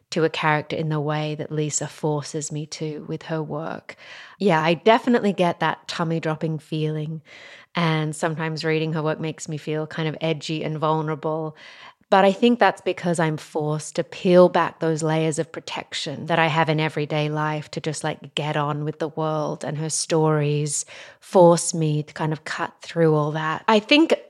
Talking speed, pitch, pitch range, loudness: 190 wpm, 160 Hz, 155-165 Hz, -22 LUFS